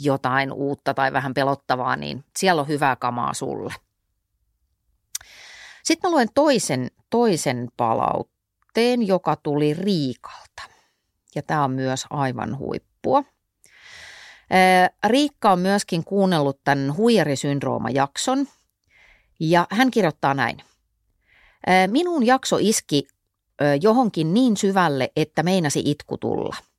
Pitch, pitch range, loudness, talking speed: 155 Hz, 140-205 Hz, -21 LUFS, 105 wpm